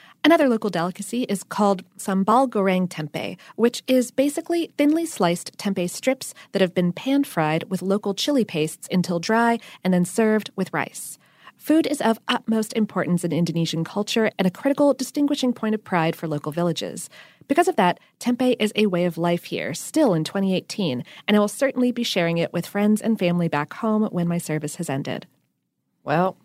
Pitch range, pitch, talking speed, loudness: 175-245 Hz, 200 Hz, 180 wpm, -22 LUFS